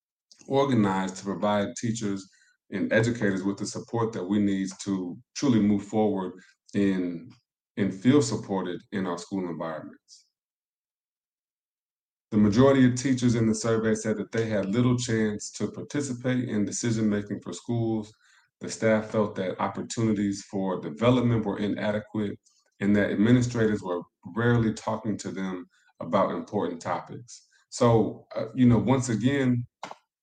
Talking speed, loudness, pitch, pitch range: 140 wpm, -26 LUFS, 110 Hz, 100-115 Hz